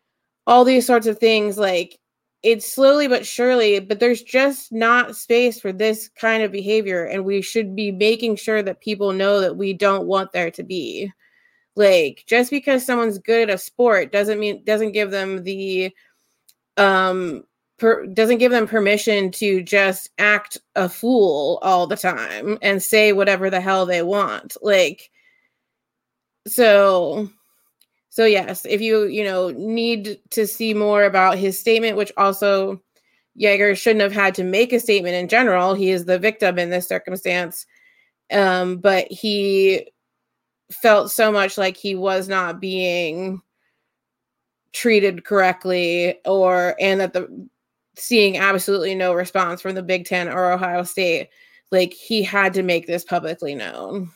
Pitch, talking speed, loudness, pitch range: 200 Hz, 155 wpm, -18 LUFS, 190-225 Hz